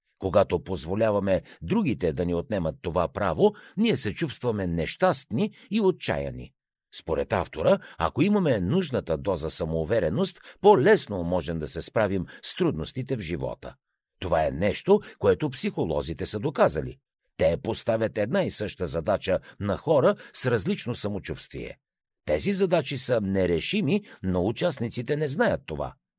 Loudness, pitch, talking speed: -26 LUFS, 120 Hz, 130 wpm